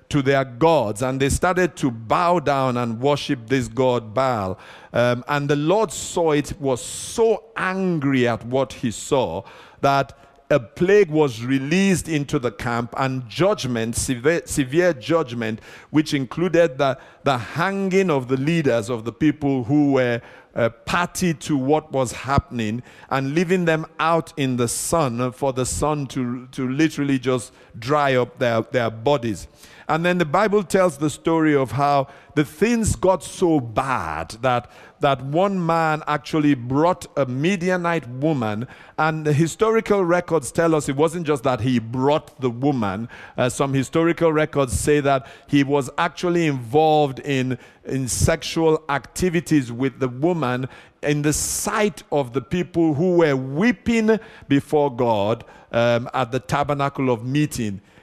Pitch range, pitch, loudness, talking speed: 130-165 Hz, 145 Hz, -21 LUFS, 155 wpm